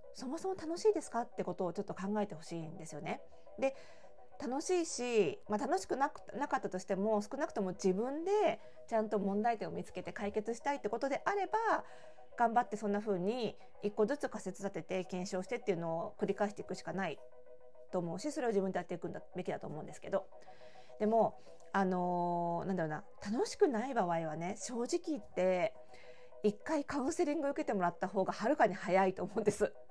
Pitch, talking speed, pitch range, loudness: 205 Hz, 415 characters per minute, 180-265 Hz, -37 LUFS